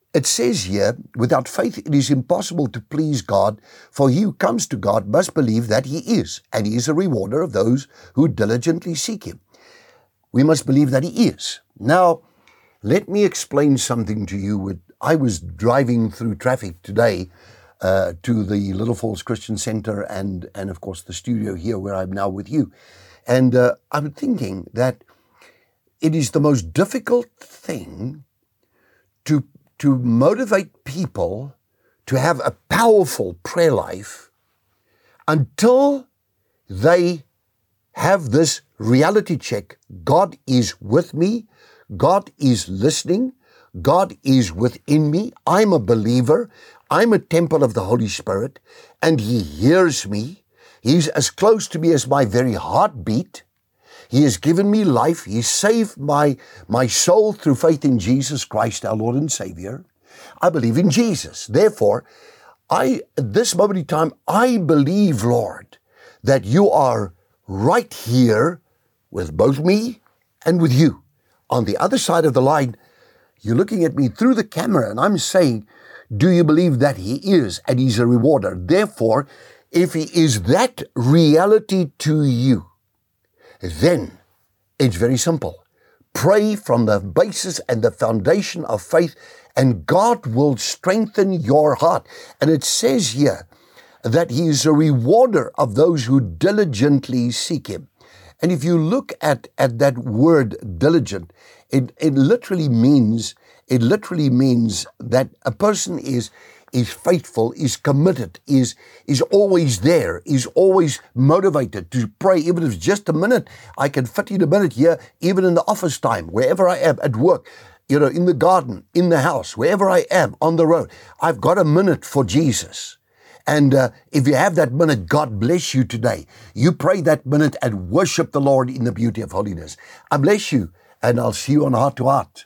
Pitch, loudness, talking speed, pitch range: 145 Hz, -18 LUFS, 160 wpm, 120-175 Hz